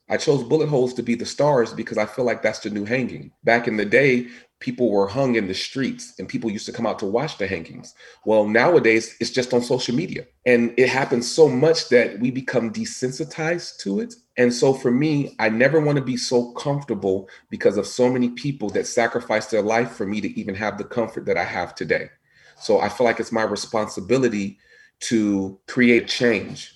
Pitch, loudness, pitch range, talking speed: 120 Hz, -21 LUFS, 110-135 Hz, 215 wpm